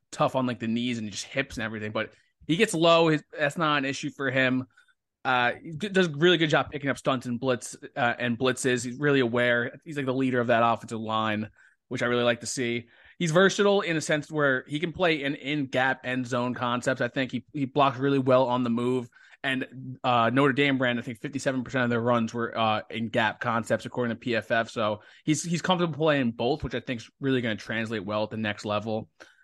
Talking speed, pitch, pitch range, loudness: 235 wpm, 130 Hz, 120-145 Hz, -26 LUFS